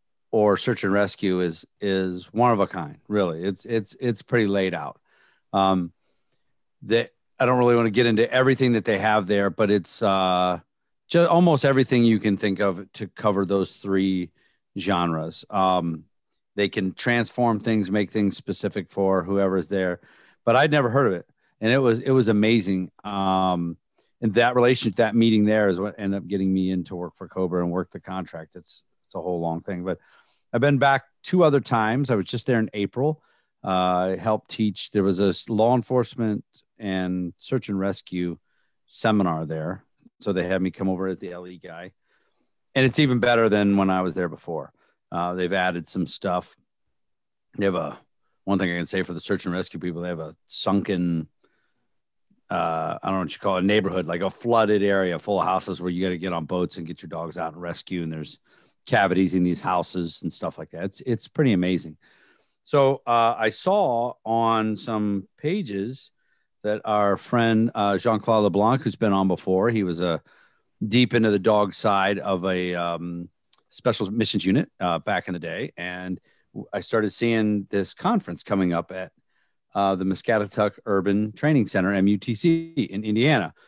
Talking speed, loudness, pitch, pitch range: 190 wpm, -23 LUFS, 100 Hz, 90-110 Hz